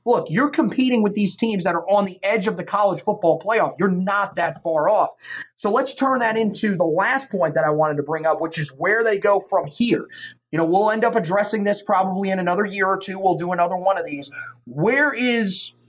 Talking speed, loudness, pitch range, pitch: 240 wpm, -20 LUFS, 180-225 Hz, 200 Hz